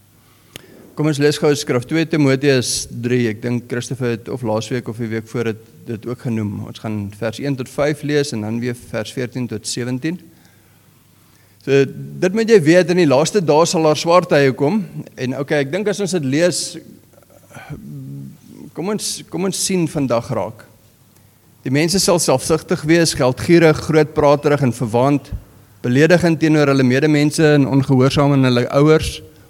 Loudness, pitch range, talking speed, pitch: -17 LUFS, 120-155 Hz, 165 wpm, 140 Hz